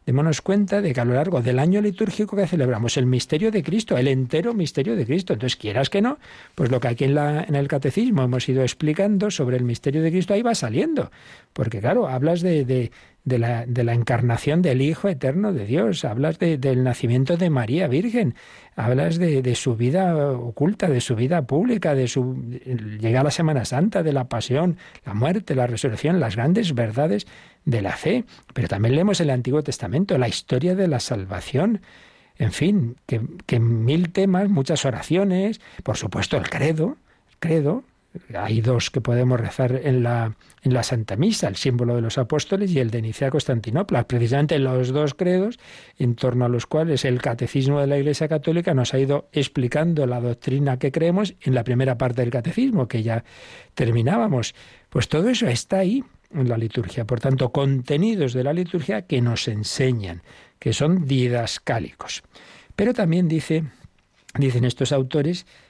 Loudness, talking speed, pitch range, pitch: -22 LUFS, 185 wpm, 125-170 Hz, 135 Hz